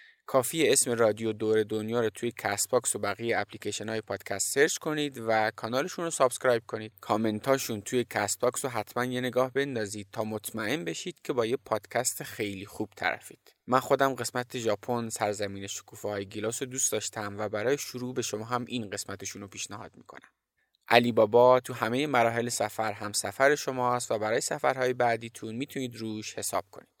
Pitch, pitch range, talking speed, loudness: 115 Hz, 105-125 Hz, 175 wpm, -29 LUFS